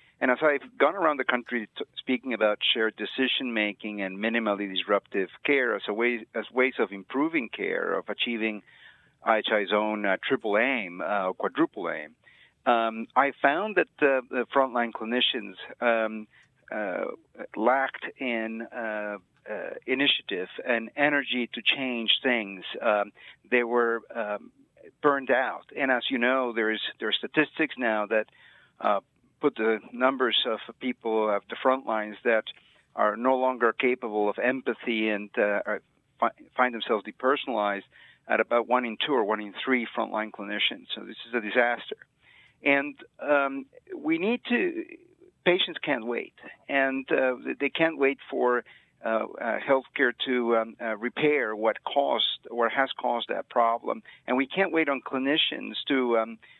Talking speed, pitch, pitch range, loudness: 155 wpm, 120 Hz, 110-135 Hz, -27 LUFS